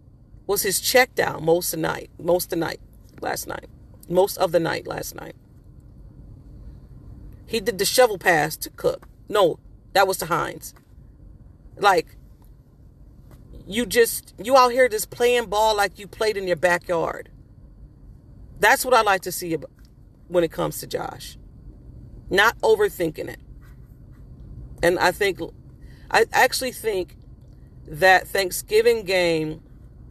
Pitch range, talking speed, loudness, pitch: 175-260 Hz, 140 wpm, -21 LUFS, 200 Hz